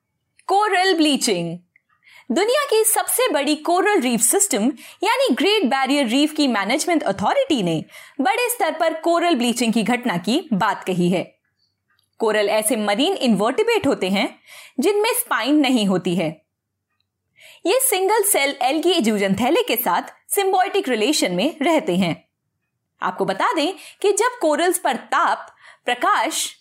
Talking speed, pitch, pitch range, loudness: 135 wpm, 300 Hz, 235-375 Hz, -19 LUFS